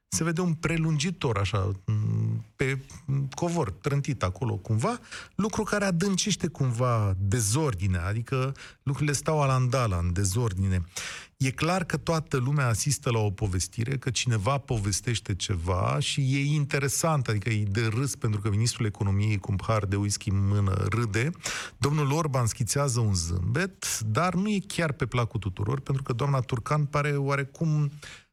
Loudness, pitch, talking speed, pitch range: -27 LUFS, 130 Hz, 150 wpm, 105-145 Hz